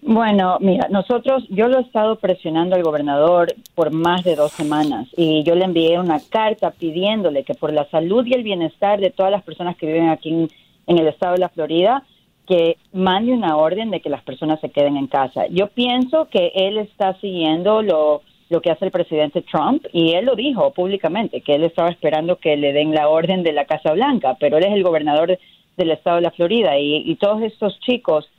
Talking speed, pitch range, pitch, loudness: 215 wpm, 155-205 Hz, 175 Hz, -18 LUFS